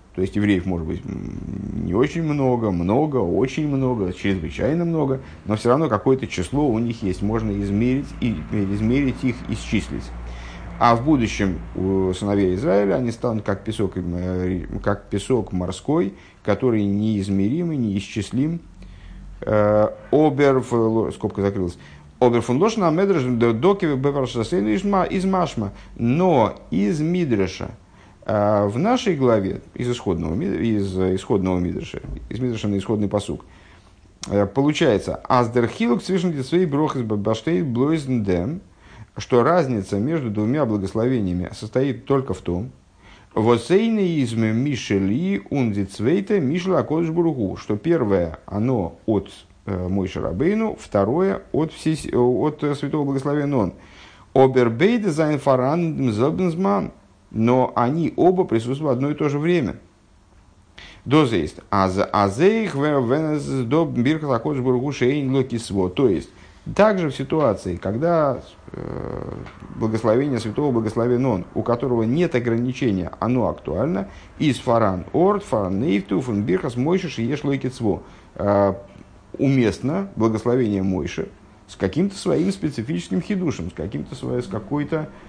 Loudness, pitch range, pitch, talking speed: -21 LUFS, 100-145 Hz, 120 Hz, 95 wpm